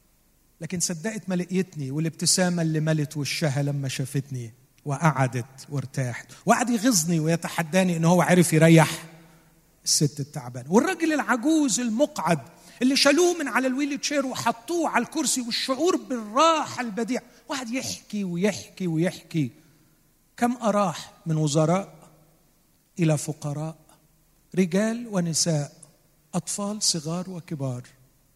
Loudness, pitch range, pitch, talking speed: -24 LUFS, 155-230 Hz, 170 Hz, 110 wpm